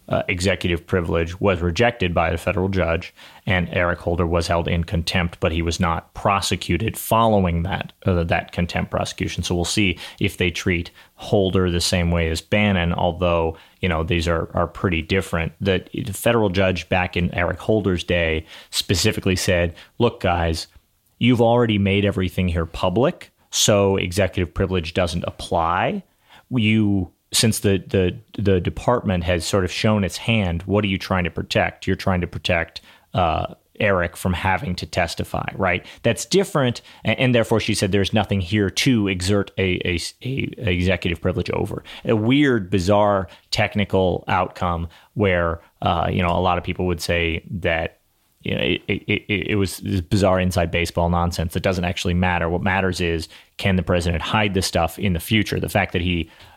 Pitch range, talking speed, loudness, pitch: 85-100 Hz, 175 wpm, -21 LUFS, 95 Hz